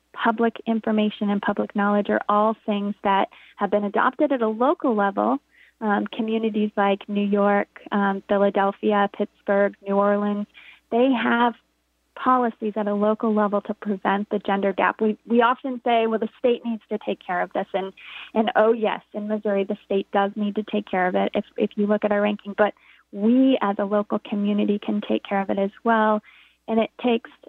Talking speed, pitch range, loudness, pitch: 195 wpm, 205-225 Hz, -23 LUFS, 210 Hz